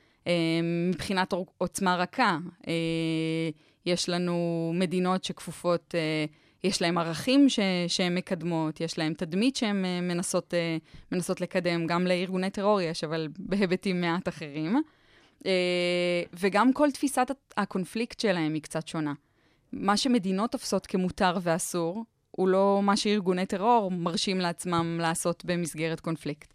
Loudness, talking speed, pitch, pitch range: -28 LUFS, 115 wpm, 180 Hz, 165-195 Hz